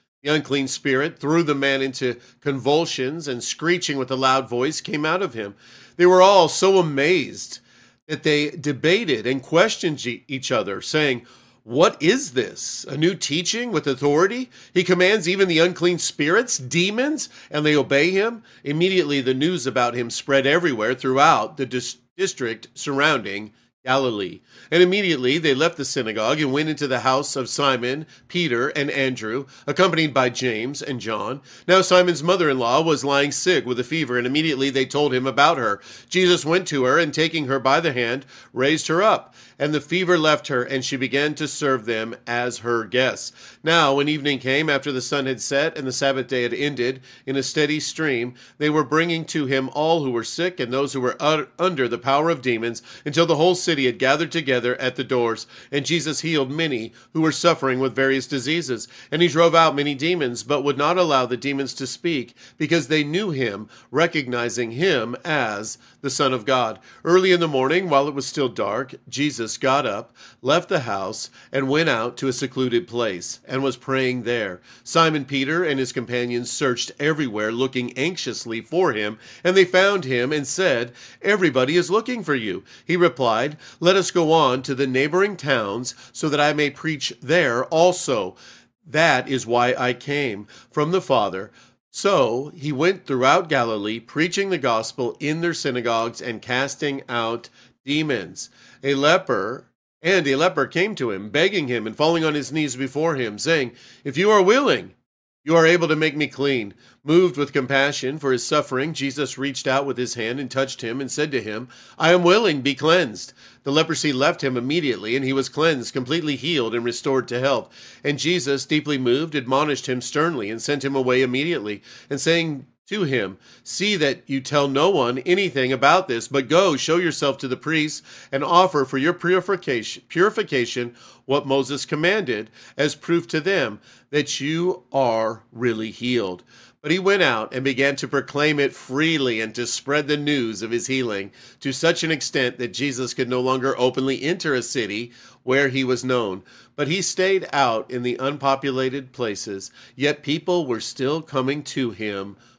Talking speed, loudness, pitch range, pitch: 185 wpm, -21 LUFS, 125-160 Hz, 140 Hz